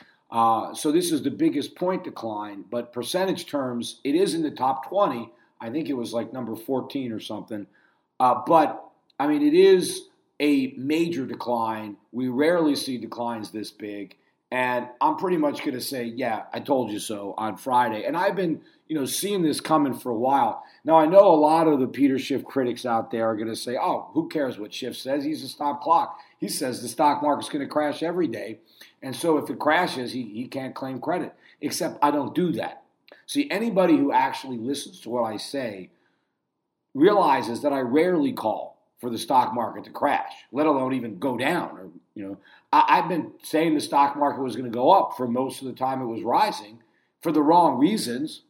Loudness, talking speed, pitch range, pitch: -24 LUFS, 210 wpm, 120-175 Hz, 140 Hz